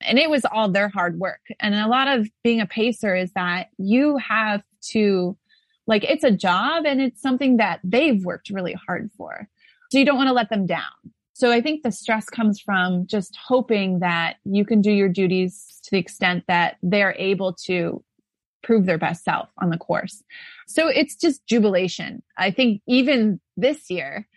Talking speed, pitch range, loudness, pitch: 195 wpm, 185-255 Hz, -21 LUFS, 210 Hz